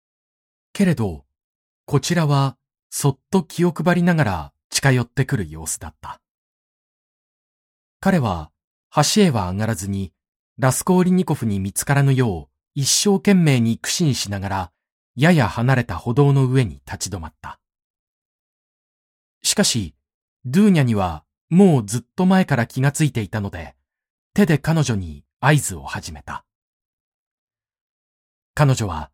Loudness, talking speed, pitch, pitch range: -19 LUFS, 250 characters per minute, 125 Hz, 95-150 Hz